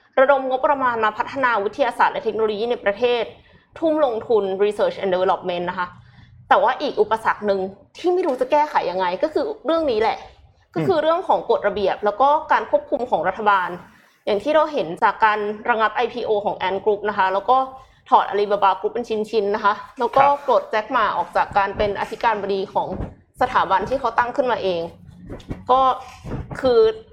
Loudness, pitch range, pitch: -20 LUFS, 200-265 Hz, 220 Hz